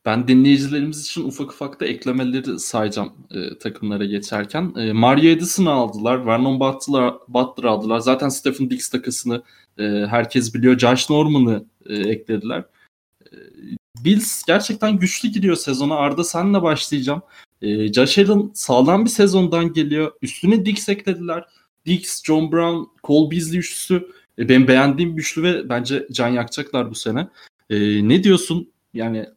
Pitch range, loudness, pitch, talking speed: 120-170 Hz, -18 LUFS, 140 Hz, 140 wpm